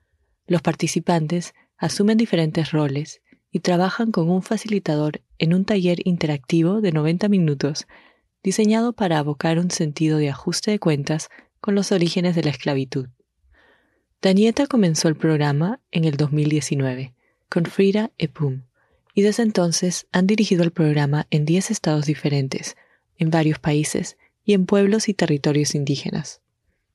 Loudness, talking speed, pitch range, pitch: -21 LUFS, 140 wpm, 150-195 Hz, 170 Hz